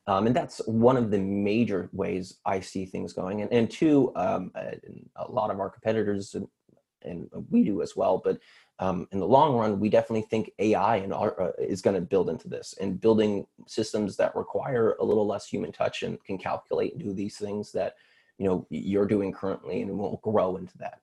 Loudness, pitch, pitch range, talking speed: -27 LUFS, 105 Hz, 100-115 Hz, 210 wpm